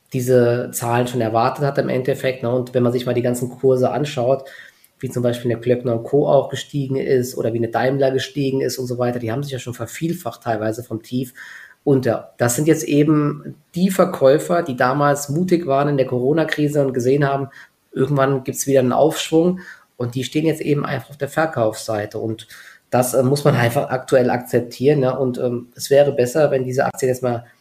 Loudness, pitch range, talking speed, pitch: -19 LUFS, 125-145 Hz, 205 wpm, 130 Hz